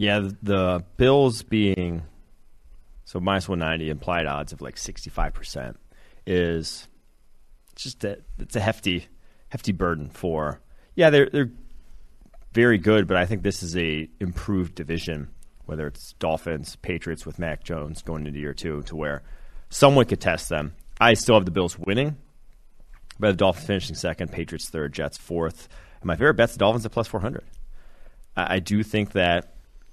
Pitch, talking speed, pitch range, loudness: 90 Hz, 170 wpm, 80-105 Hz, -24 LUFS